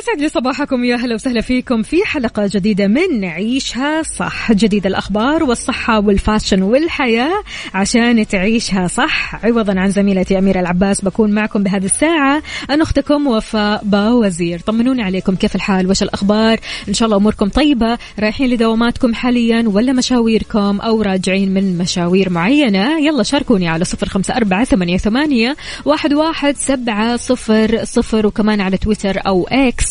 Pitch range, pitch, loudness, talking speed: 200-255 Hz, 220 Hz, -14 LUFS, 145 wpm